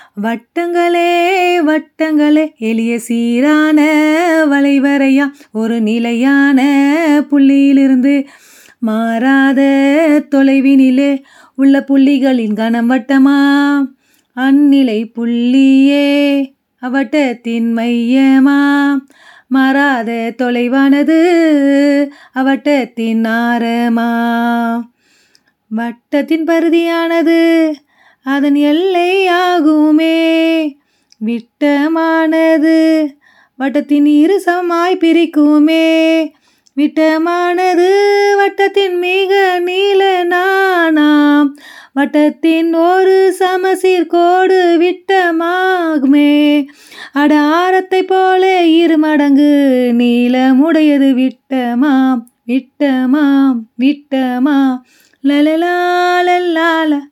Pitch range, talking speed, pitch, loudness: 270-330 Hz, 55 wpm, 290 Hz, -11 LUFS